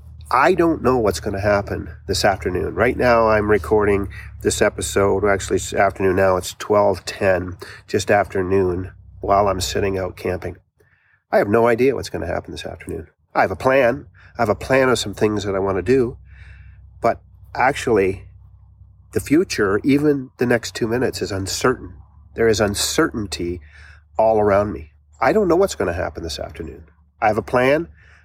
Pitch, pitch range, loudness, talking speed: 95 Hz, 90-110 Hz, -19 LUFS, 185 wpm